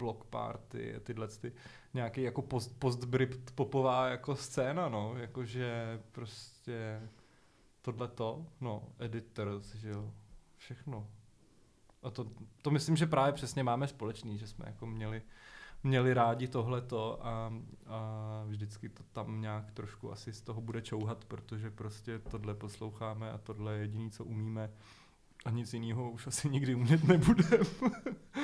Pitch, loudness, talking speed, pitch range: 115 Hz, -36 LUFS, 140 wpm, 110-130 Hz